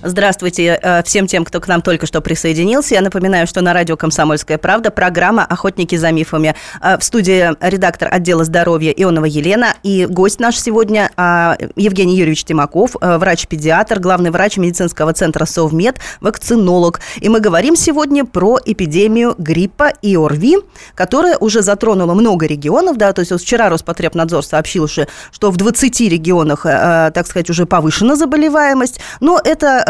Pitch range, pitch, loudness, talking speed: 170-215 Hz, 180 Hz, -12 LUFS, 145 wpm